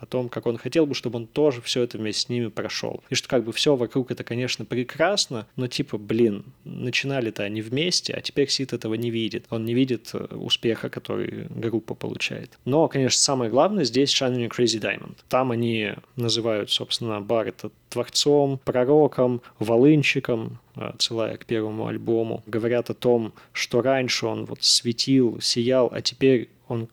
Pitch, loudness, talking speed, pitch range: 120 Hz, -23 LUFS, 165 wpm, 115-130 Hz